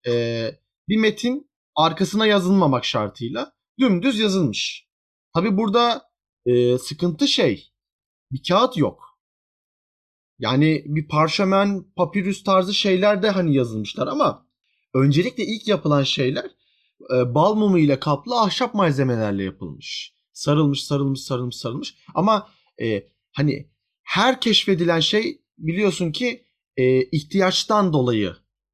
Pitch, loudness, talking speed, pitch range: 165 Hz, -21 LUFS, 110 wpm, 130-205 Hz